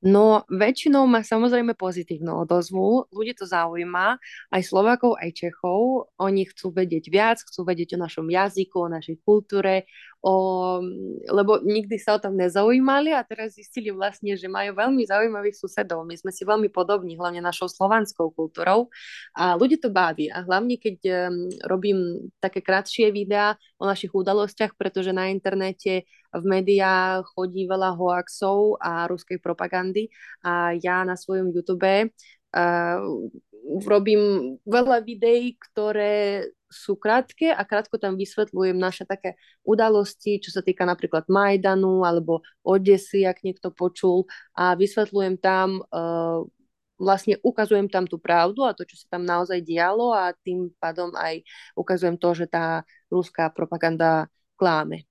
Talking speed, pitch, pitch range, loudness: 145 wpm, 190 Hz, 180-210 Hz, -23 LUFS